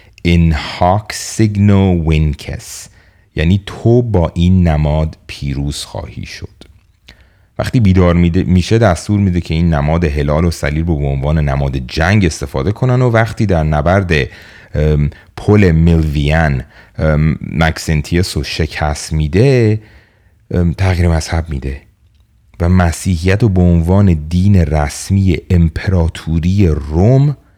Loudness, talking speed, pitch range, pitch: -13 LUFS, 115 wpm, 80-100 Hz, 90 Hz